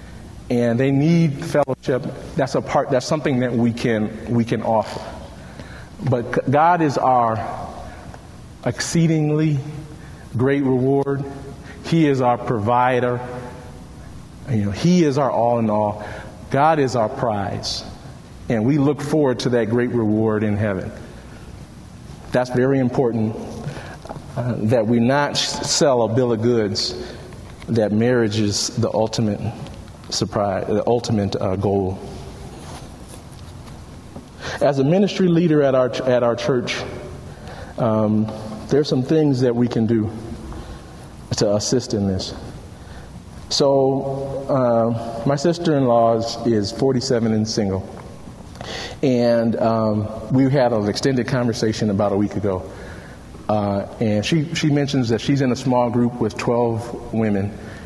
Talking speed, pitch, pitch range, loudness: 135 wpm, 120 Hz, 110-135 Hz, -19 LUFS